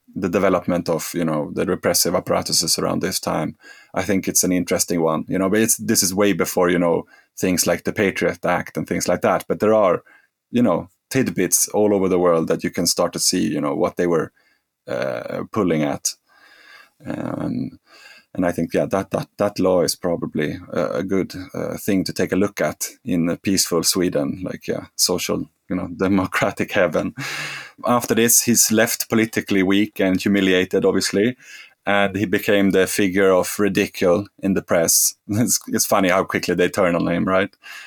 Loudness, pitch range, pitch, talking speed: -19 LUFS, 90-105 Hz, 95 Hz, 190 wpm